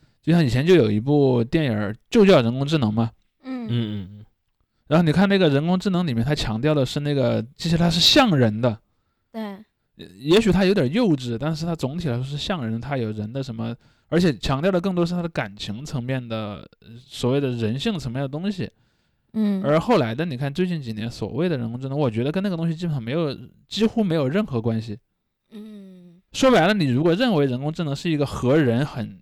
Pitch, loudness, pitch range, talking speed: 145 Hz, -21 LUFS, 115-175 Hz, 315 characters per minute